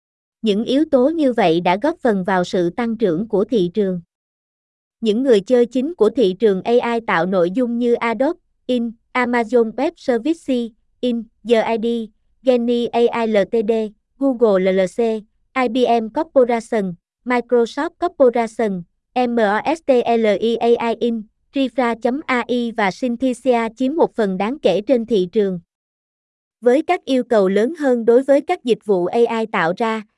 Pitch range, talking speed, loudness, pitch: 215-255 Hz, 140 wpm, -18 LUFS, 235 Hz